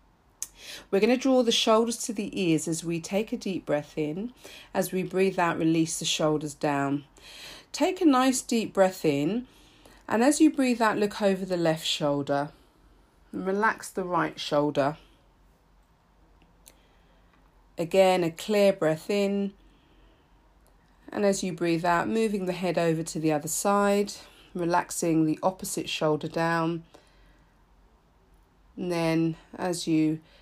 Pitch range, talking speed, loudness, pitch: 150-200 Hz, 140 wpm, -26 LUFS, 170 Hz